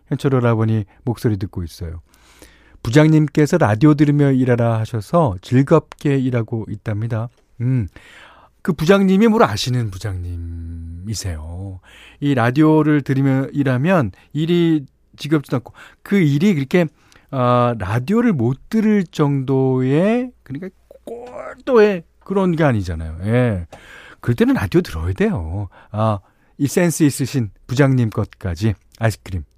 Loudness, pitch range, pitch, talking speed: -18 LUFS, 105-155 Hz, 125 Hz, 280 characters per minute